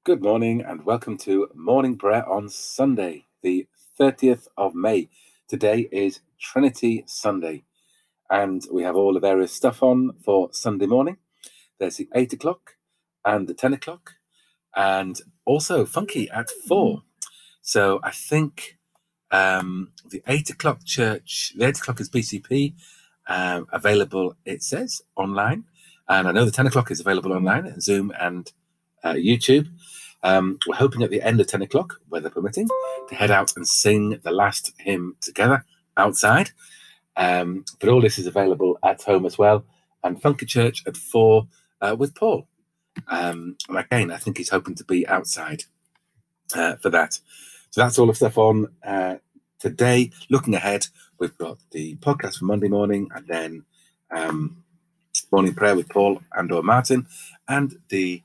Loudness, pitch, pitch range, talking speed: -22 LUFS, 115 Hz, 95-135 Hz, 155 wpm